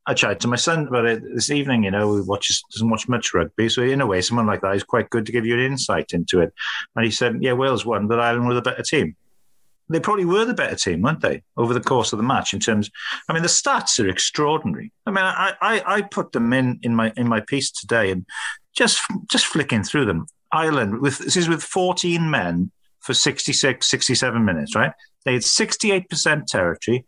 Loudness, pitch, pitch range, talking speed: -20 LUFS, 125 Hz, 115-160 Hz, 230 wpm